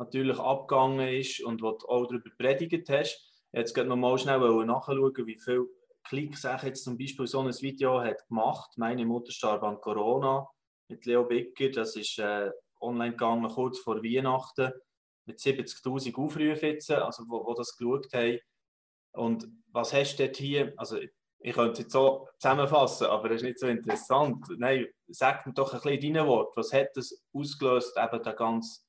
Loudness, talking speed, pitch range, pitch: -30 LUFS, 185 wpm, 115-135 Hz, 130 Hz